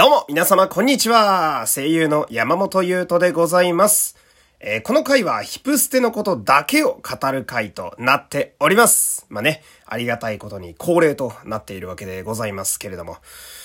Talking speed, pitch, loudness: 360 characters per minute, 170 Hz, -17 LUFS